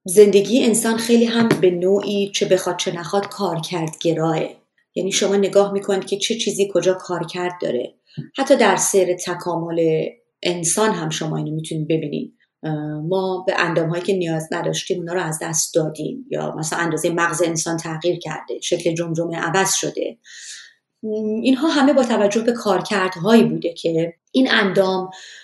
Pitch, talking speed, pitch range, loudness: 185 Hz, 160 wpm, 170-200 Hz, -19 LUFS